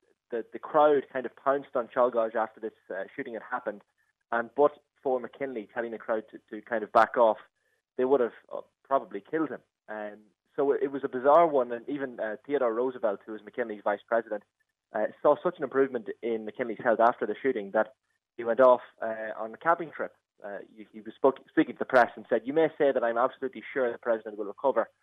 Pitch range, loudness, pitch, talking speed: 110-140 Hz, -28 LUFS, 120 Hz, 220 wpm